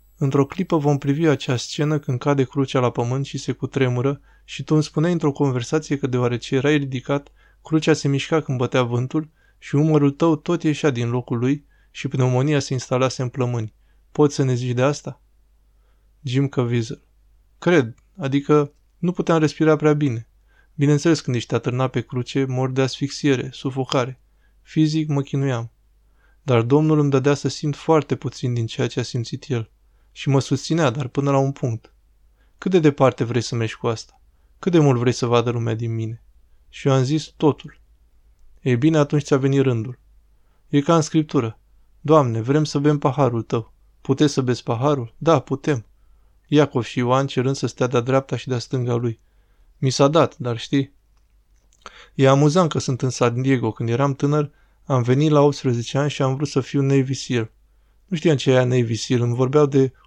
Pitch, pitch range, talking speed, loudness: 135 Hz, 120-145 Hz, 185 wpm, -21 LUFS